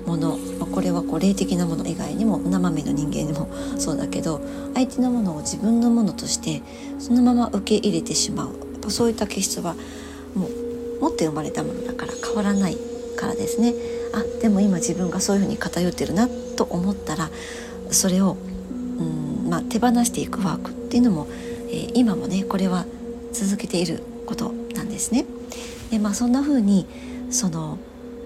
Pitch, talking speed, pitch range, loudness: 230 Hz, 360 characters per minute, 195-240 Hz, -23 LUFS